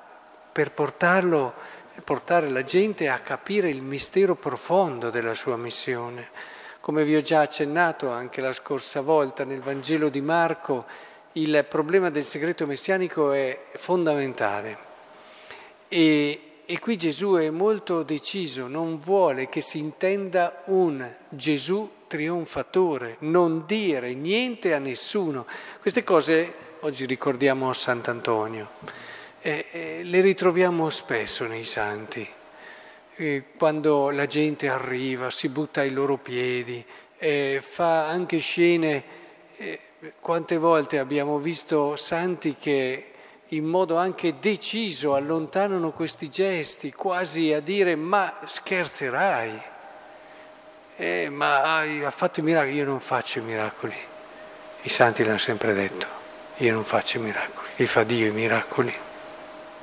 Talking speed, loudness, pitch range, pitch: 125 wpm, -25 LUFS, 135-175 Hz, 155 Hz